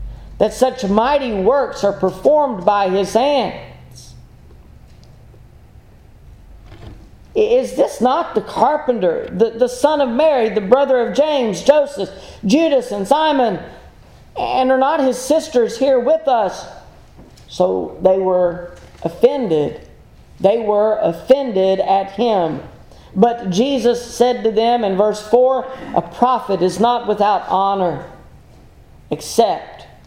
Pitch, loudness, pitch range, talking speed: 225 Hz, -16 LUFS, 190-265 Hz, 120 wpm